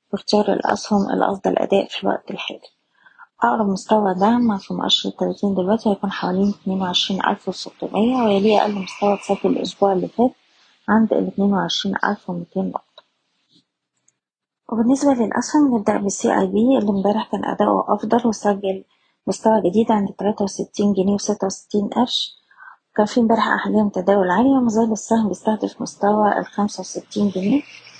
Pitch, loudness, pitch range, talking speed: 205 Hz, -19 LUFS, 195-225 Hz, 140 wpm